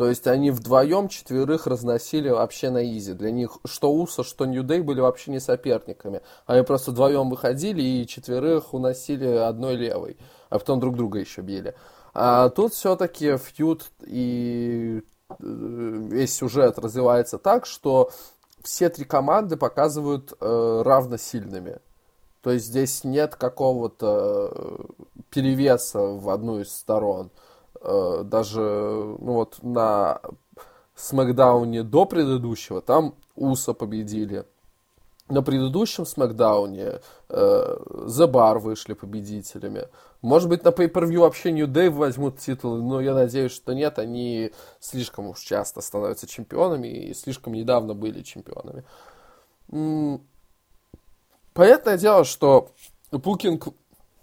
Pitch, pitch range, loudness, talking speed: 130 Hz, 115-150 Hz, -23 LUFS, 120 wpm